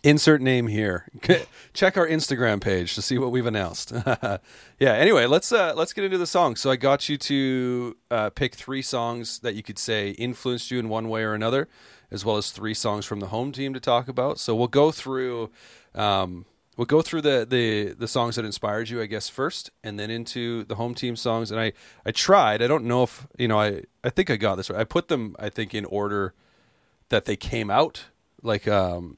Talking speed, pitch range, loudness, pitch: 220 wpm, 105-130 Hz, -24 LUFS, 120 Hz